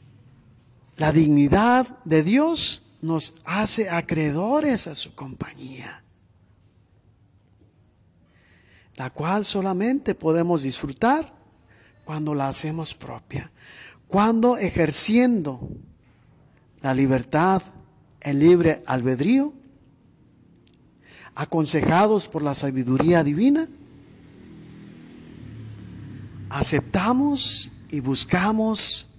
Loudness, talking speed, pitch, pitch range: -20 LUFS, 70 wpm, 150 Hz, 120-190 Hz